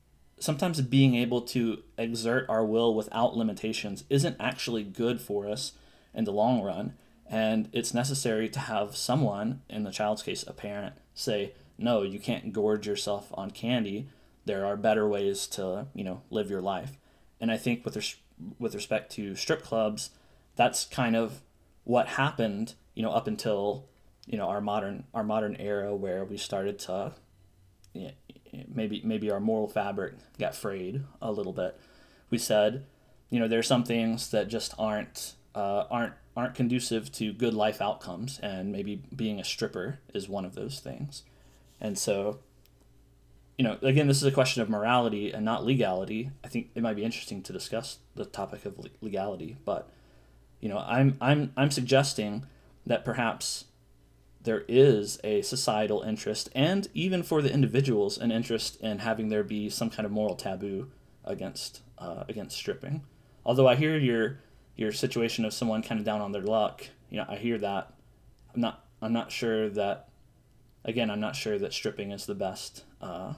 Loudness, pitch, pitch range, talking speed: -30 LUFS, 110 Hz, 105-125 Hz, 175 wpm